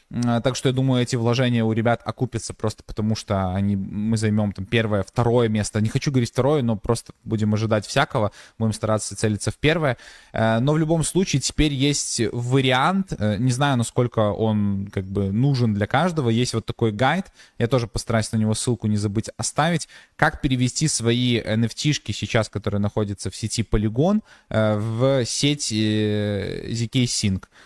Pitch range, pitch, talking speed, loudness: 110-130 Hz, 115 Hz, 165 wpm, -22 LUFS